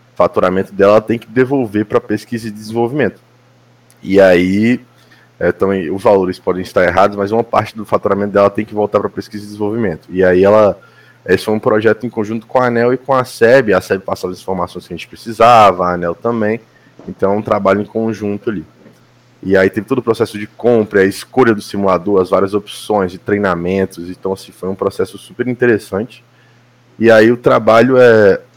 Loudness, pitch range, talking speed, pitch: -13 LUFS, 95-115 Hz, 200 wpm, 105 Hz